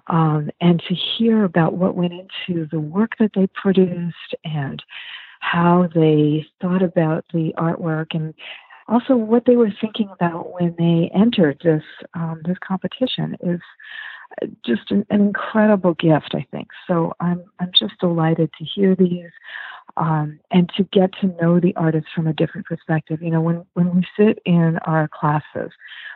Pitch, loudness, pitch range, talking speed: 175 Hz, -19 LUFS, 165-195 Hz, 165 wpm